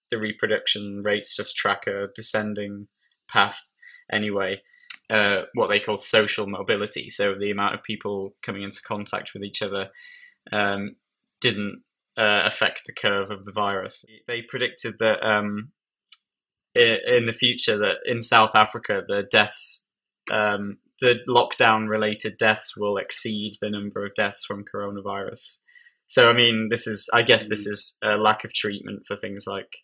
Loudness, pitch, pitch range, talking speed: -21 LUFS, 105 Hz, 100-120 Hz, 145 wpm